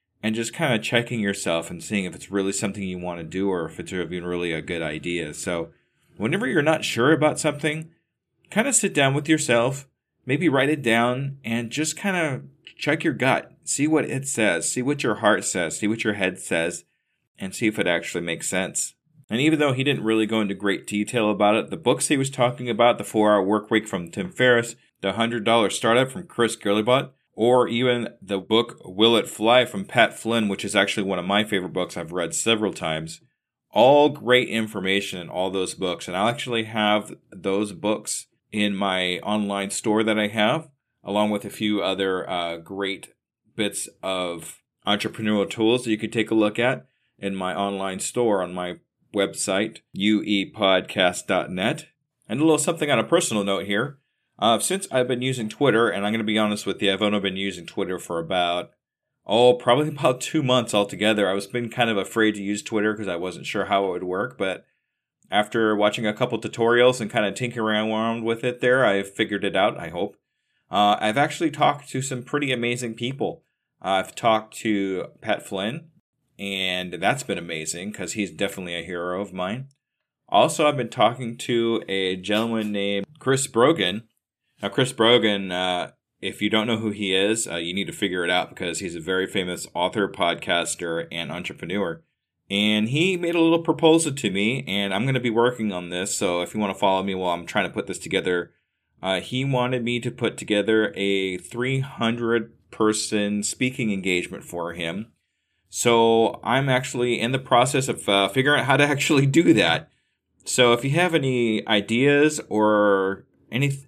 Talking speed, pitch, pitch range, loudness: 195 wpm, 110 Hz, 100-125 Hz, -23 LUFS